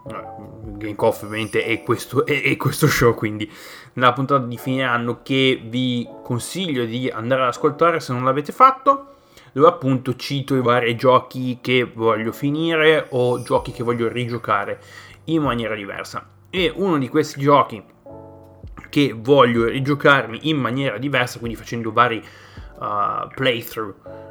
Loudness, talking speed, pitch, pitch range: -19 LUFS, 145 wpm, 125 Hz, 115-145 Hz